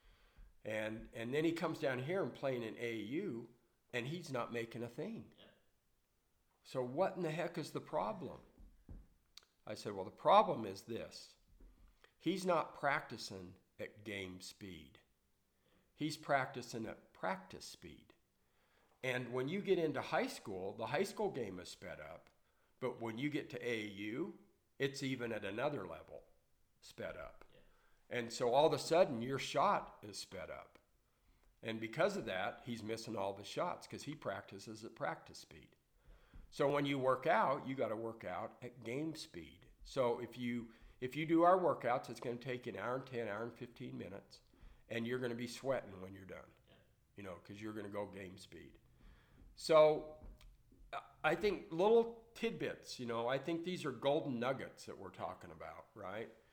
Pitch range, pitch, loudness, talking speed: 115-150 Hz, 125 Hz, -40 LUFS, 170 wpm